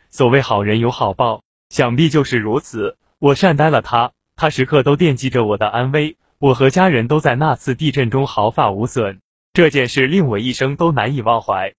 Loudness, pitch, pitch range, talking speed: -16 LUFS, 135 Hz, 120-150 Hz, 285 characters per minute